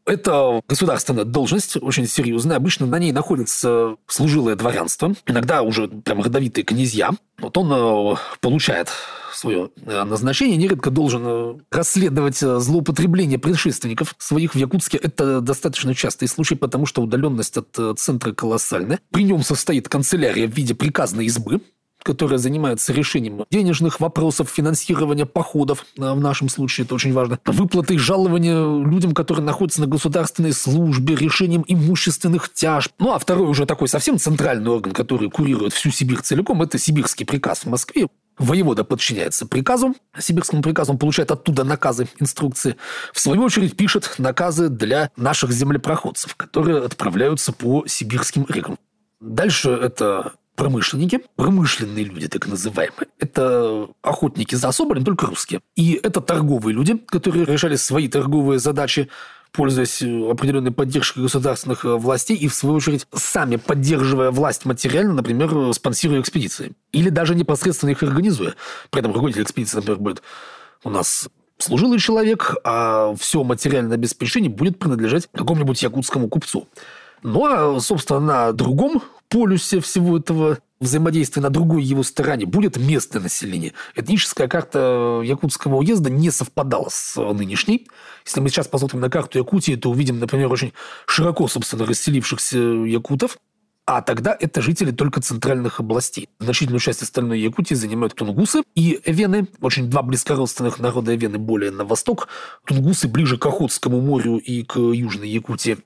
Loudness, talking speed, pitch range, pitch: -19 LUFS, 140 wpm, 125-165 Hz, 145 Hz